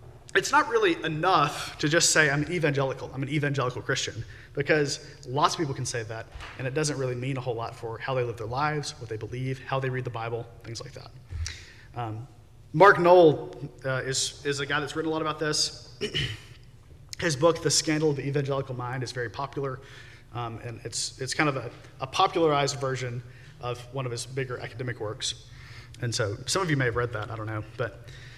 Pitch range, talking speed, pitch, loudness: 120-145 Hz, 210 wpm, 130 Hz, -27 LUFS